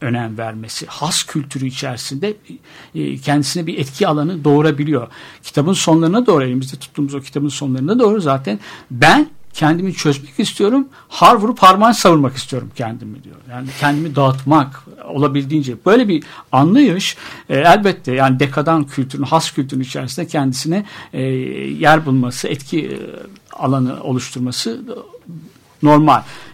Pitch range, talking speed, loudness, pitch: 130-165 Hz, 120 wpm, -15 LUFS, 145 Hz